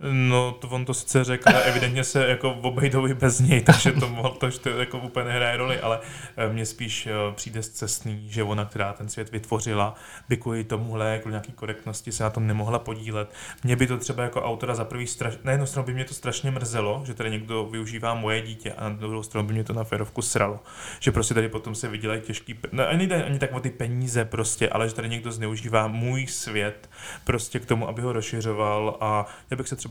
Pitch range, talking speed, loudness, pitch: 110-125 Hz, 225 wpm, -25 LUFS, 115 Hz